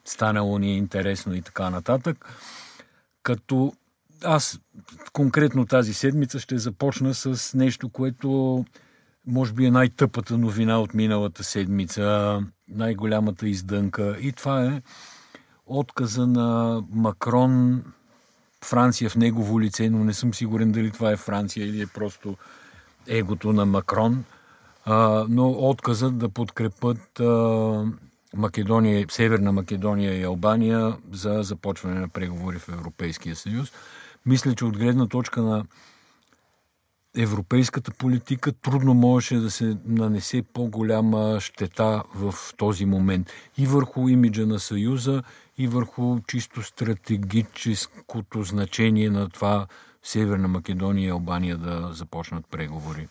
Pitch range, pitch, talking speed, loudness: 100-125 Hz, 110 Hz, 120 wpm, -24 LUFS